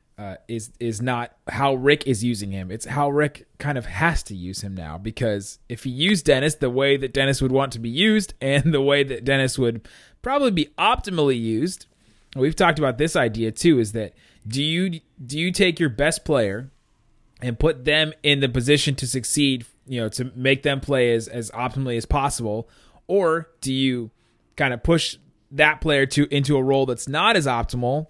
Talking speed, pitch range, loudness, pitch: 200 wpm, 115-150 Hz, -21 LUFS, 135 Hz